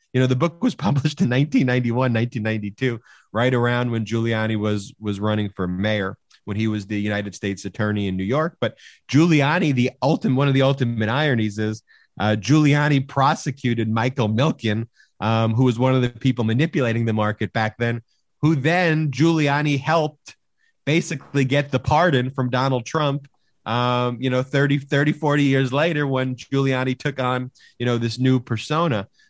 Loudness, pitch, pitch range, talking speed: -21 LUFS, 125 Hz, 110-145 Hz, 170 wpm